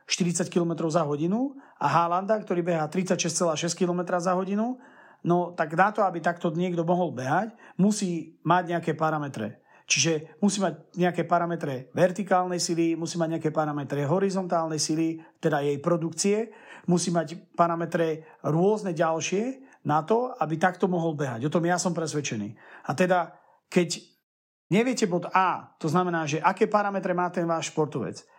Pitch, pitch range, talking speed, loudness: 175 Hz, 160-185 Hz, 150 wpm, -26 LUFS